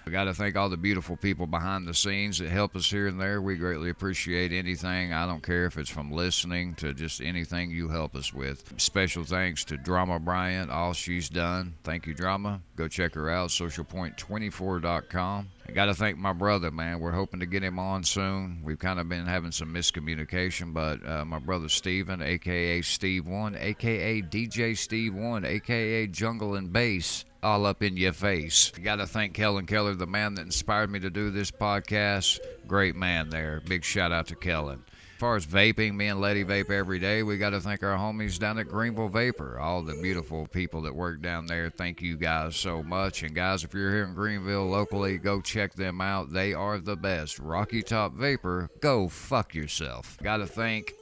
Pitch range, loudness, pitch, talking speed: 85-100 Hz, -29 LUFS, 95 Hz, 200 wpm